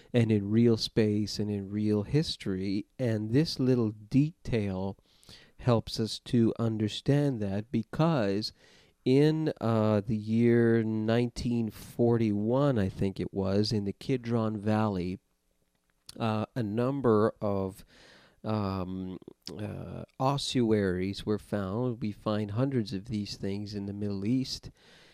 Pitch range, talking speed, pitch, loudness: 100-120 Hz, 120 wpm, 110 Hz, -30 LUFS